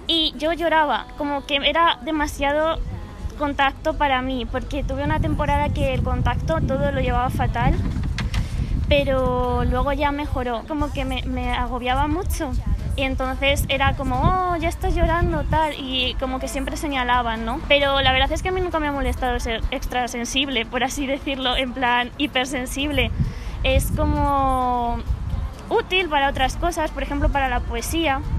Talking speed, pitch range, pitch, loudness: 160 wpm, 255-300 Hz, 275 Hz, -22 LUFS